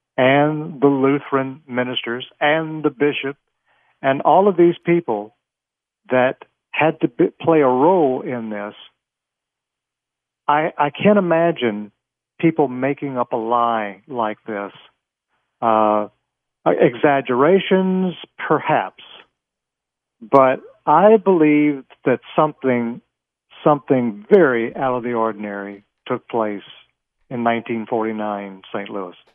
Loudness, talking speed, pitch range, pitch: -18 LUFS, 105 wpm, 115-150 Hz, 130 Hz